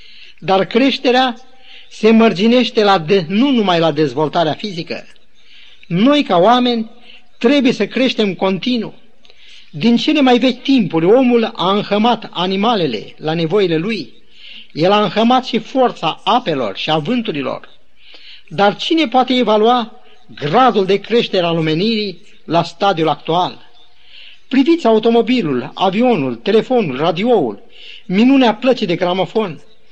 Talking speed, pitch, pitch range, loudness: 120 wpm, 220 Hz, 185-245 Hz, -14 LUFS